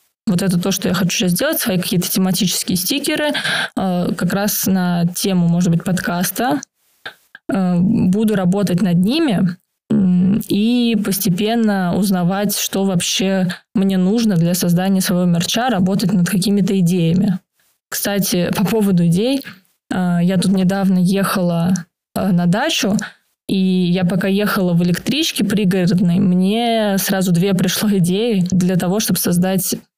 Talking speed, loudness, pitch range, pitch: 130 wpm, -16 LUFS, 180-205 Hz, 190 Hz